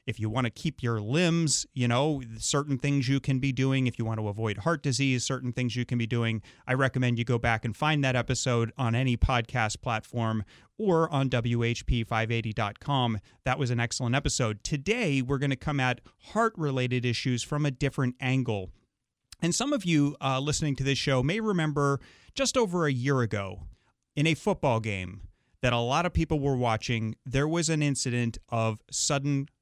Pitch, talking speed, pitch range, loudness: 130 Hz, 195 wpm, 115-145 Hz, -28 LUFS